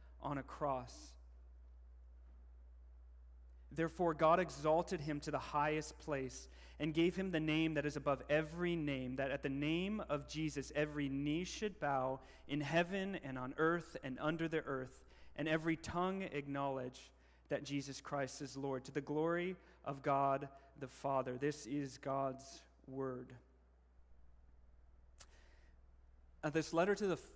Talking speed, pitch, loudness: 145 wpm, 140 Hz, -40 LUFS